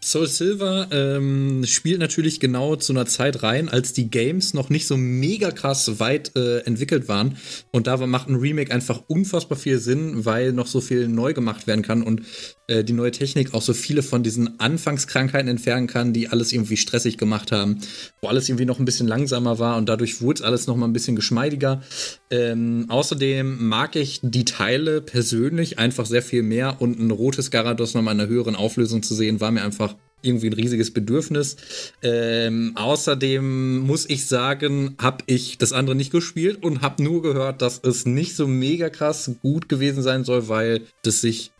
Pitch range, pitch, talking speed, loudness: 115-140 Hz, 125 Hz, 190 wpm, -21 LUFS